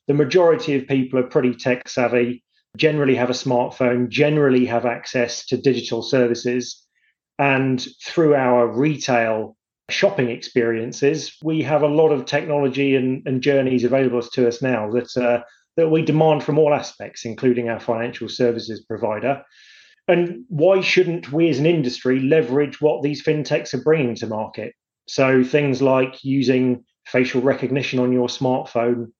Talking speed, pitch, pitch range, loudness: 150 wpm, 130 Hz, 120-150 Hz, -19 LUFS